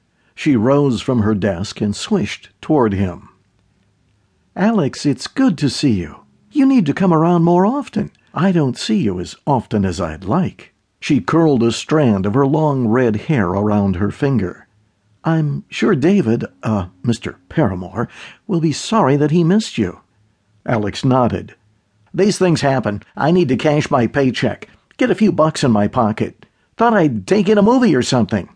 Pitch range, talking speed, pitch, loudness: 105-160 Hz, 170 wpm, 125 Hz, -16 LUFS